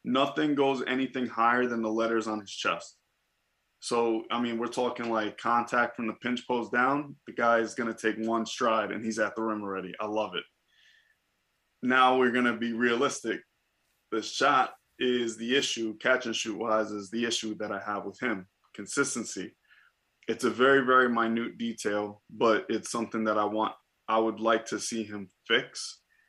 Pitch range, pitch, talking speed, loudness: 110-125 Hz, 115 Hz, 185 wpm, -29 LUFS